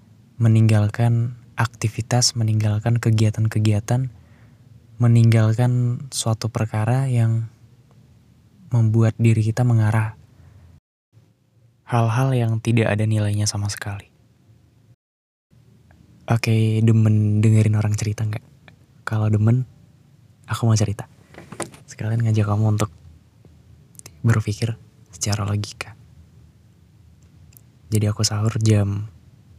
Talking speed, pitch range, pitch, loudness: 85 wpm, 105-120 Hz, 110 Hz, -20 LUFS